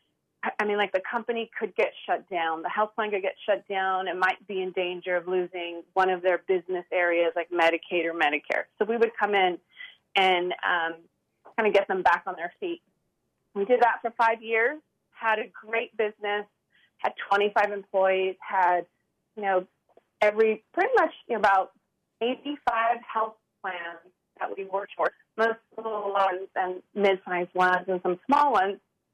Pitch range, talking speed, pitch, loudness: 180-225 Hz, 180 wpm, 195 Hz, -26 LUFS